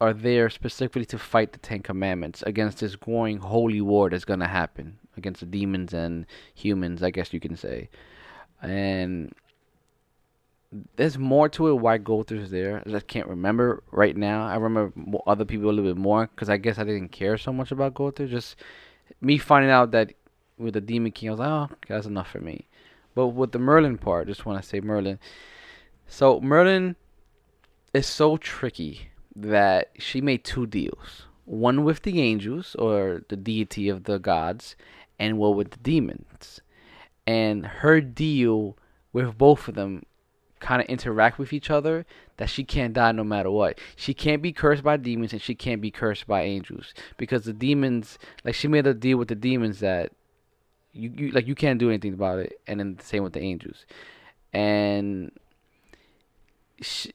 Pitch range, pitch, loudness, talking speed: 100-130 Hz, 110 Hz, -24 LUFS, 185 wpm